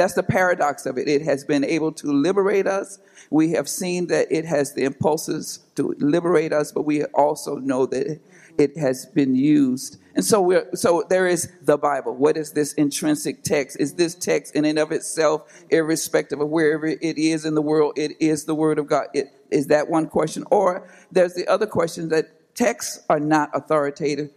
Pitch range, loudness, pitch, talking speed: 150-175 Hz, -21 LUFS, 155 Hz, 200 wpm